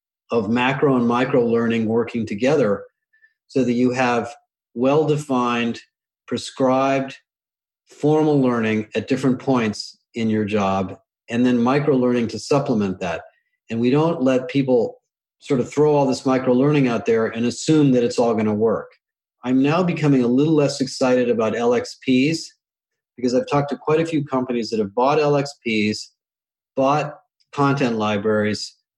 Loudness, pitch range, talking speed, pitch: -20 LUFS, 115-145 Hz, 155 wpm, 130 Hz